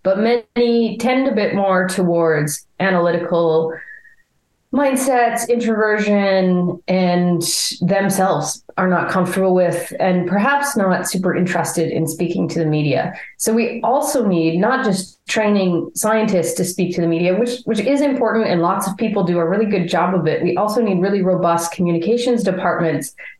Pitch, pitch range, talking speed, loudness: 185 Hz, 175-225 Hz, 155 wpm, -17 LUFS